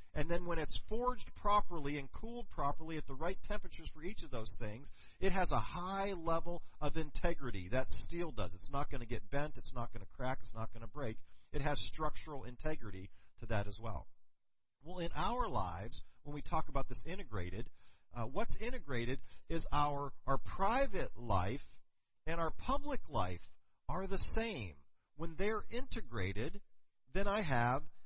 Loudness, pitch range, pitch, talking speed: -41 LUFS, 115-175 Hz, 145 Hz, 180 wpm